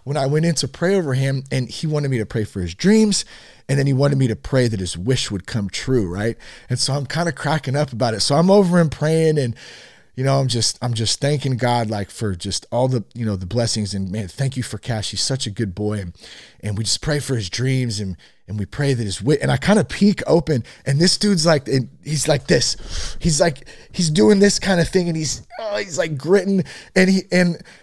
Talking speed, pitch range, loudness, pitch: 260 wpm, 110-160 Hz, -19 LUFS, 135 Hz